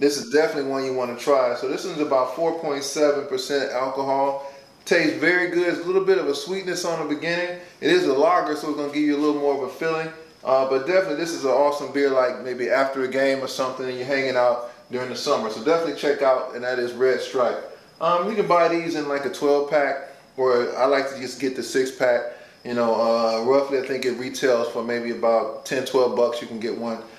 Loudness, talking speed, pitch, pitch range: -22 LUFS, 245 wpm, 140 Hz, 130-160 Hz